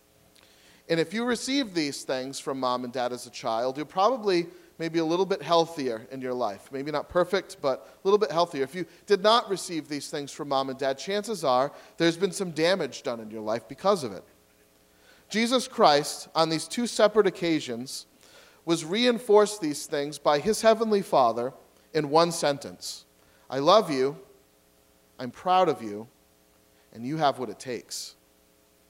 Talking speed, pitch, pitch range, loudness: 180 wpm, 150 Hz, 120-190 Hz, -26 LUFS